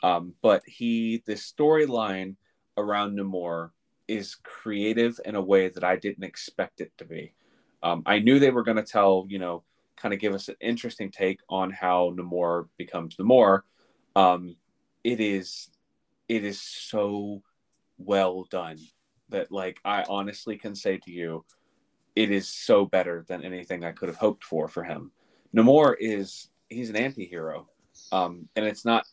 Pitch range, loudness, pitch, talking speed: 90-110 Hz, -26 LUFS, 100 Hz, 165 wpm